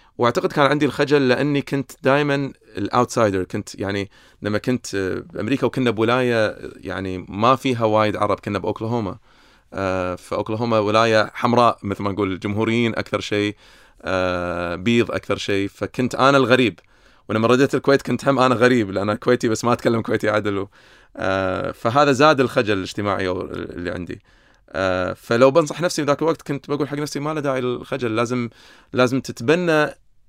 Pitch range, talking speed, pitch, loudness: 100-135 Hz, 155 wpm, 115 Hz, -20 LUFS